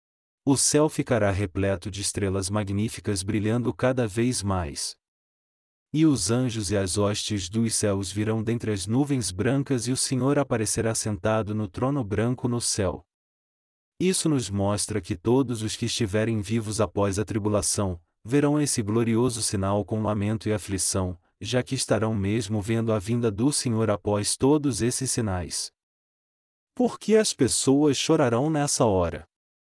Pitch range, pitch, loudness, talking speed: 105-125 Hz, 110 Hz, -25 LUFS, 150 wpm